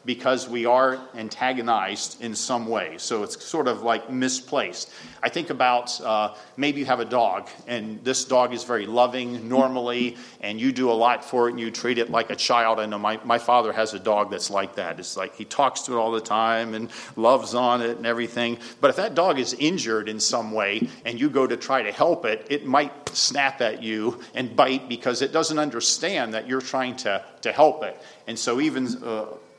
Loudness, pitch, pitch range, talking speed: -24 LUFS, 120 Hz, 115-130 Hz, 220 wpm